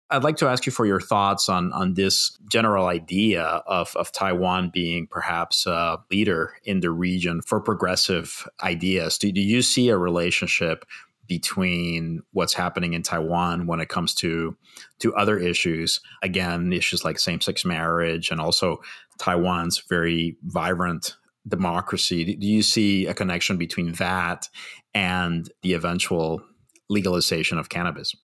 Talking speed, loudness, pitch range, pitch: 145 wpm, -23 LUFS, 85-95 Hz, 90 Hz